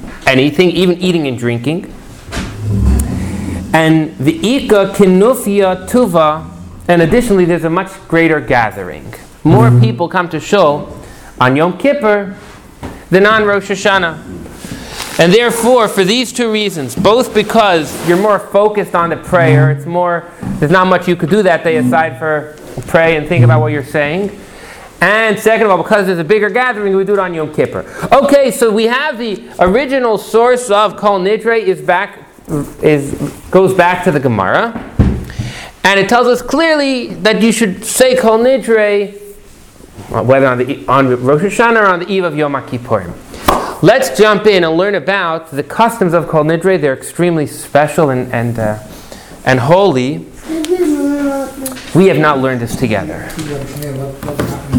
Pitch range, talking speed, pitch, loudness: 150-210 Hz, 160 wpm, 180 Hz, -12 LUFS